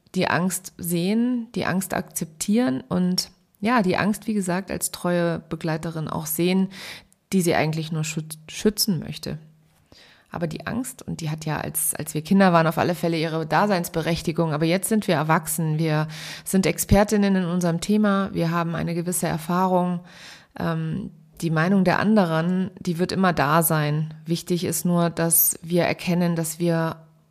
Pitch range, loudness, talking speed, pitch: 165-190 Hz, -23 LUFS, 165 wpm, 175 Hz